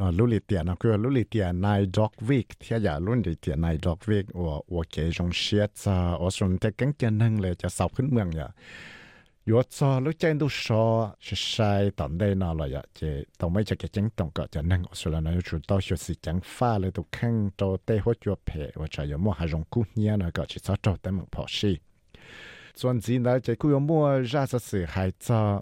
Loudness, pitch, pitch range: -27 LUFS, 100 Hz, 85-115 Hz